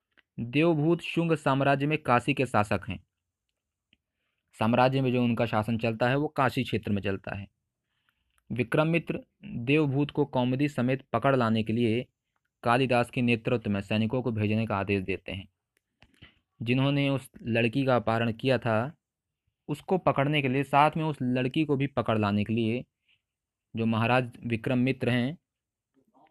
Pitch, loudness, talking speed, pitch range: 125 Hz, -27 LUFS, 155 wpm, 110-135 Hz